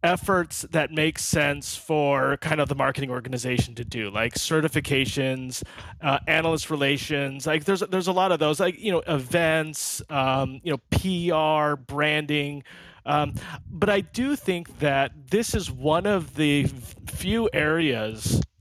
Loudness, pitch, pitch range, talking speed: -24 LUFS, 150 Hz, 130-160 Hz, 150 wpm